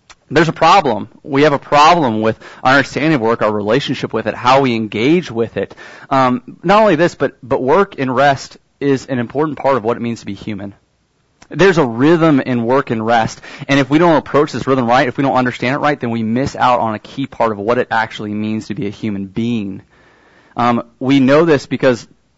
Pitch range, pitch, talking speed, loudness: 115-140 Hz, 130 Hz, 230 wpm, -14 LUFS